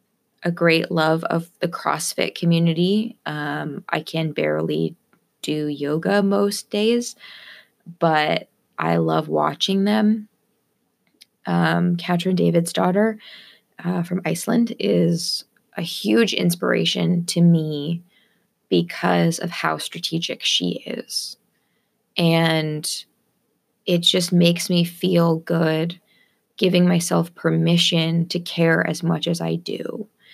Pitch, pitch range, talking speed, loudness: 170 Hz, 160-195 Hz, 110 wpm, -21 LUFS